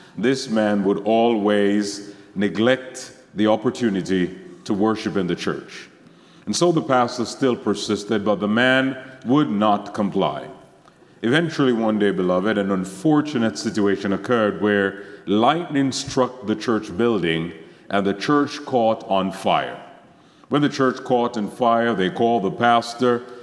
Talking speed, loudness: 140 wpm, -21 LUFS